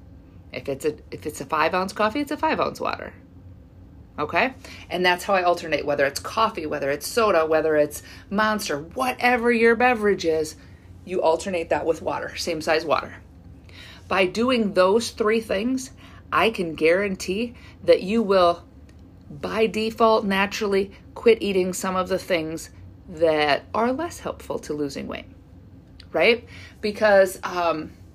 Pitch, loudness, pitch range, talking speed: 175 Hz, -22 LUFS, 140-215 Hz, 150 wpm